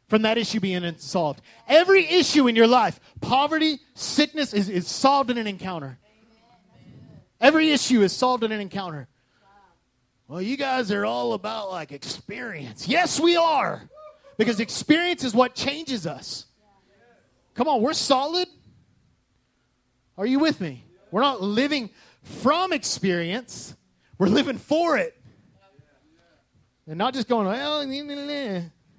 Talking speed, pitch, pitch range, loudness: 130 wpm, 240 Hz, 190-290 Hz, -23 LUFS